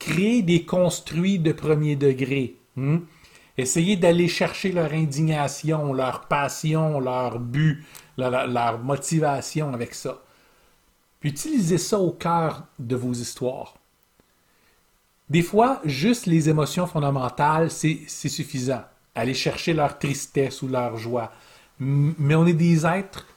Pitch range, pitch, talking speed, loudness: 135-170 Hz, 150 Hz, 125 wpm, -23 LUFS